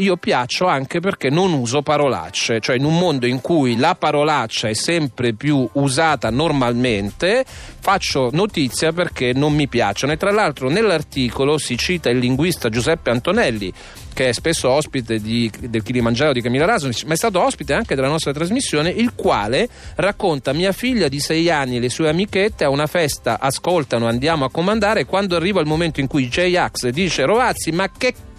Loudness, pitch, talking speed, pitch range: -18 LUFS, 150 Hz, 180 wpm, 125-170 Hz